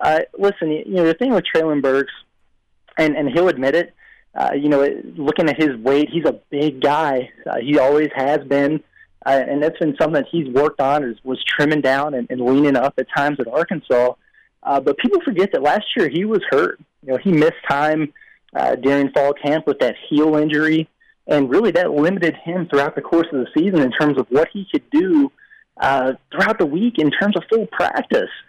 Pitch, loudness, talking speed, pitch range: 150 Hz, -18 LUFS, 210 wpm, 140-170 Hz